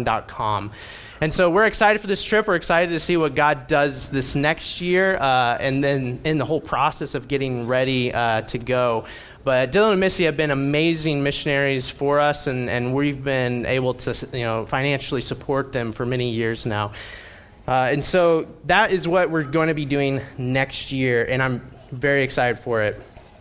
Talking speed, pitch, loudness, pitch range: 190 wpm, 135 Hz, -21 LUFS, 125-155 Hz